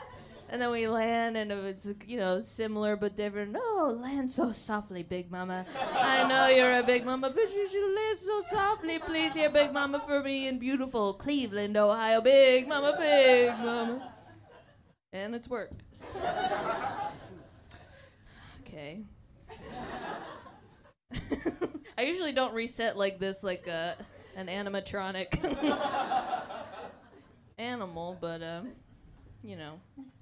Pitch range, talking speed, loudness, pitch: 205-290 Hz, 125 wpm, -29 LUFS, 245 Hz